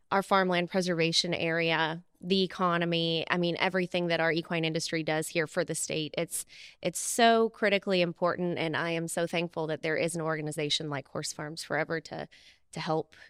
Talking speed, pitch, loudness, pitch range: 180 wpm, 170 Hz, -29 LUFS, 160-180 Hz